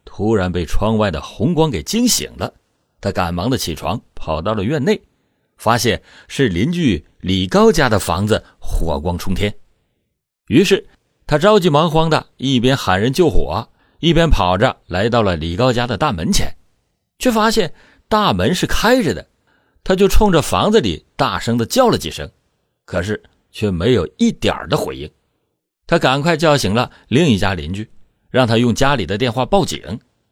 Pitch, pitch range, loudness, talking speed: 115 Hz, 100-155 Hz, -17 LUFS, 240 characters per minute